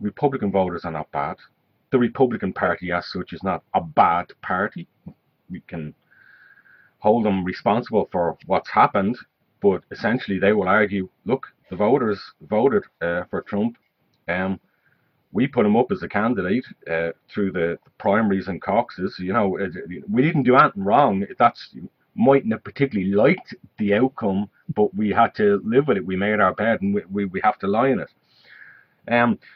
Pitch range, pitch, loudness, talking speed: 95-110 Hz, 100 Hz, -21 LUFS, 175 wpm